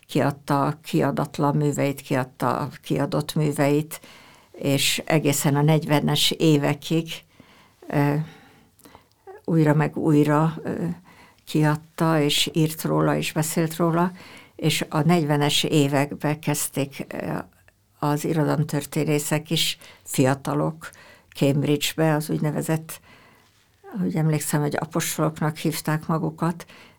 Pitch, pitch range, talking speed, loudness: 150 Hz, 145-160 Hz, 100 wpm, -23 LUFS